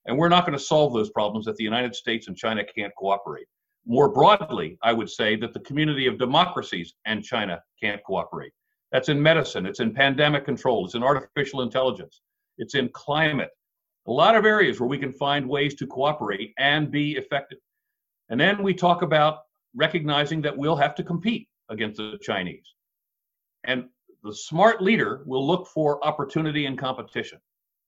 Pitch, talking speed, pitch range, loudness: 145 Hz, 175 wpm, 130-175 Hz, -23 LUFS